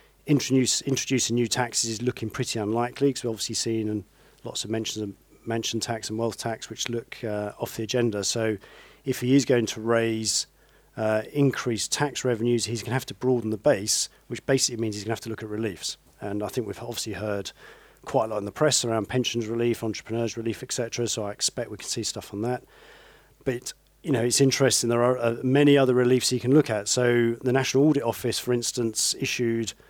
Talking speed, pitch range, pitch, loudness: 215 wpm, 110-130 Hz, 115 Hz, -25 LUFS